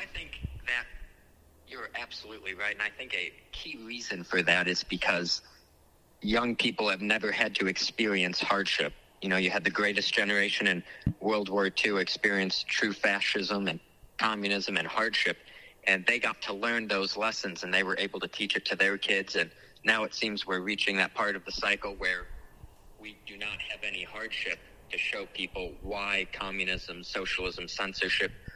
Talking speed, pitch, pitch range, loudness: 175 wpm, 100 Hz, 90-105 Hz, -29 LUFS